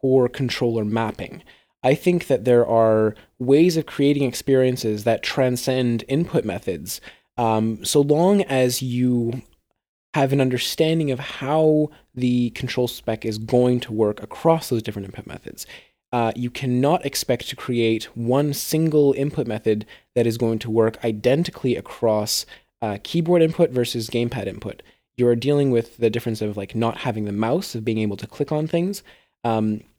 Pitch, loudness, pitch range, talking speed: 125 Hz, -21 LUFS, 115-140 Hz, 160 wpm